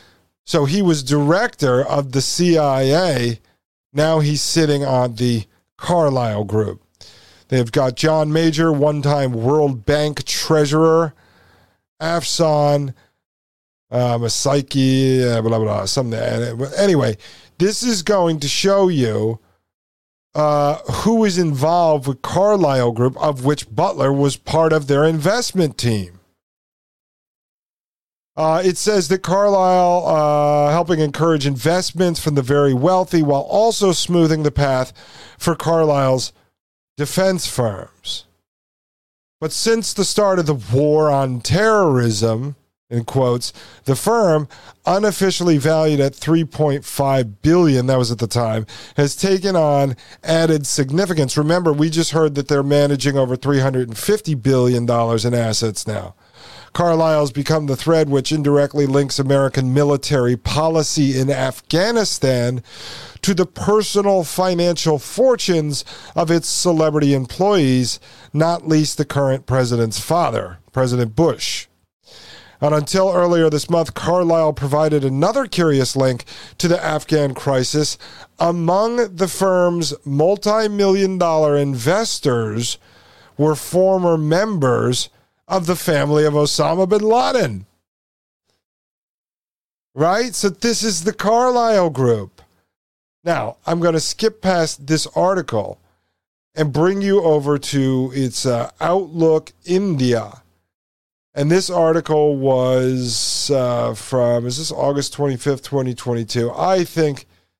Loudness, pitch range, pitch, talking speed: -17 LUFS, 125-165 Hz, 145 Hz, 120 wpm